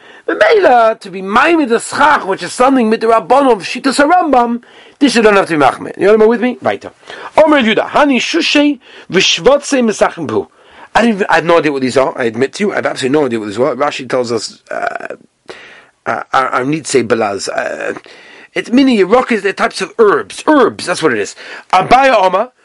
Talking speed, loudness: 225 wpm, -12 LUFS